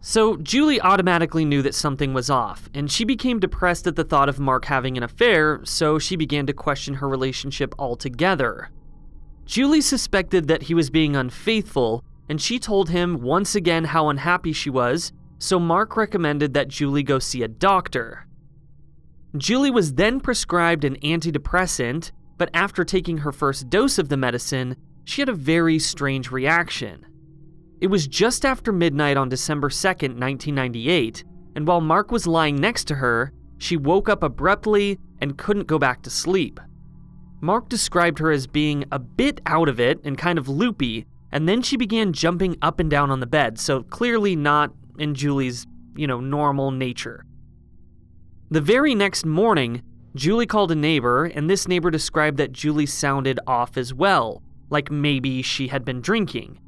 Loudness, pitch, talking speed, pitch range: -21 LUFS, 155 Hz, 170 wpm, 140-180 Hz